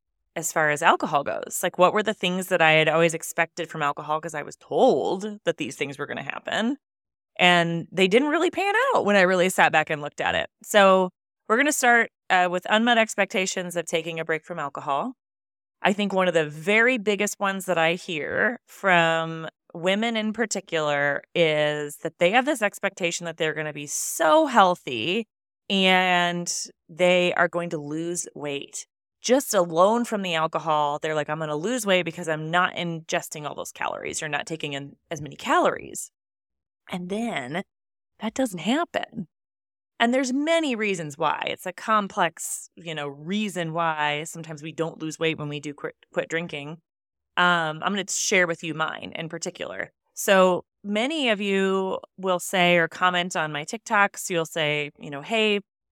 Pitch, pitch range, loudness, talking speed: 175 Hz, 160-205 Hz, -23 LUFS, 185 wpm